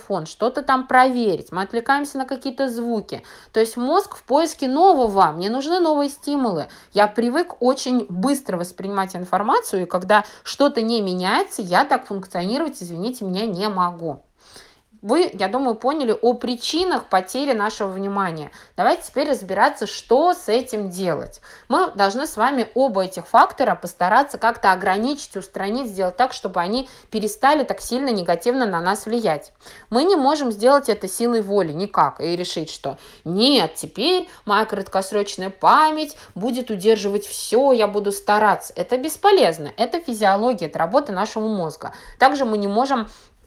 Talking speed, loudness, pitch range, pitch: 150 wpm, -20 LUFS, 195-265 Hz, 225 Hz